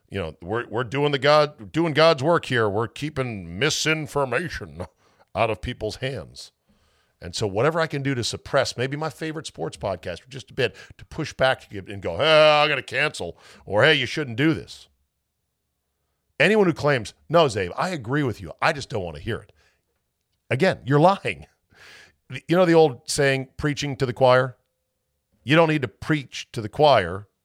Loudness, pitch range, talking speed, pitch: -22 LUFS, 105-150 Hz, 190 wpm, 130 Hz